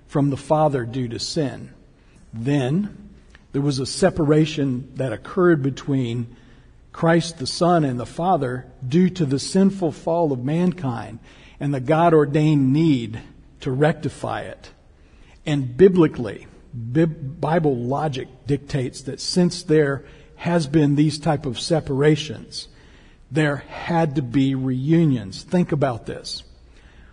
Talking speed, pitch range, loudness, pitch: 125 wpm, 130-160 Hz, -21 LUFS, 145 Hz